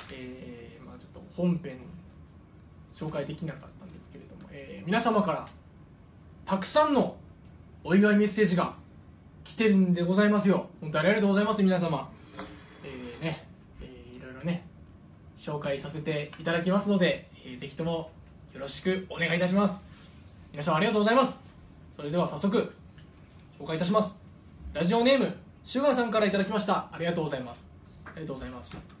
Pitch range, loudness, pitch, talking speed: 140-200 Hz, -28 LUFS, 170 Hz, 365 characters per minute